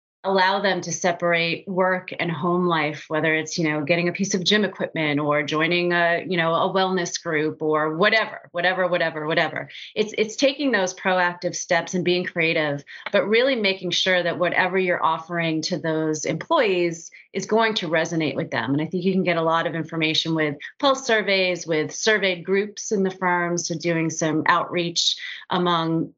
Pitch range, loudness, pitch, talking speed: 160-185 Hz, -22 LUFS, 175 Hz, 185 wpm